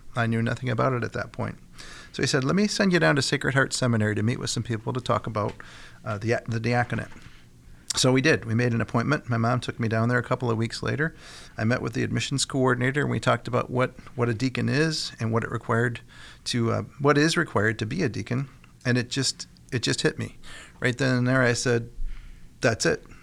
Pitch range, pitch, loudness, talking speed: 115-130 Hz, 120 Hz, -25 LUFS, 240 wpm